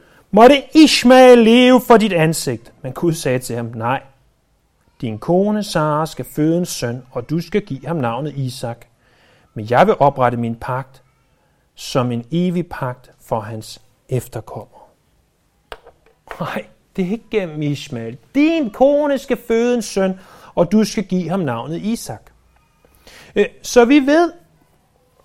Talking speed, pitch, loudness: 145 wpm, 160 Hz, -16 LUFS